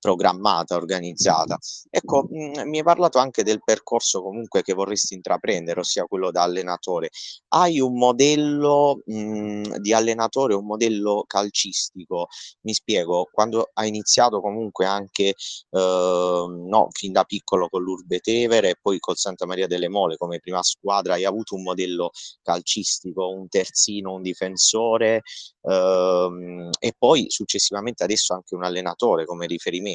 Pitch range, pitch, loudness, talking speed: 90-115 Hz, 100 Hz, -22 LUFS, 140 wpm